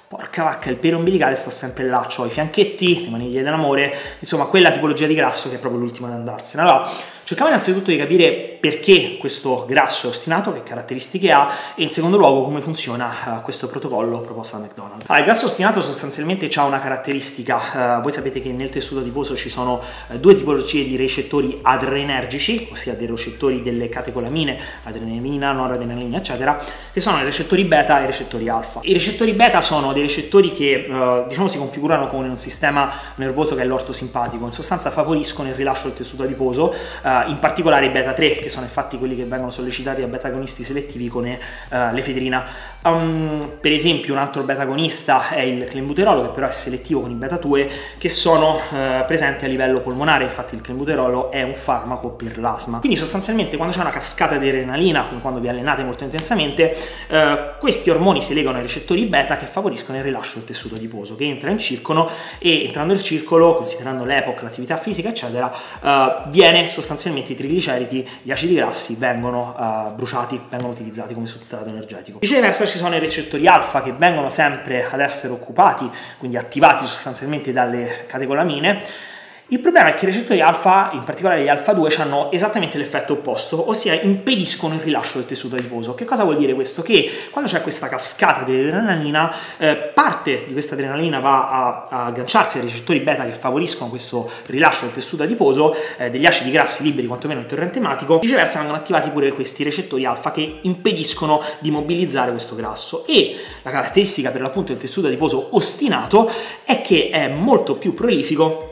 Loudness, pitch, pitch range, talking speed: -18 LUFS, 140 Hz, 125-160 Hz, 180 wpm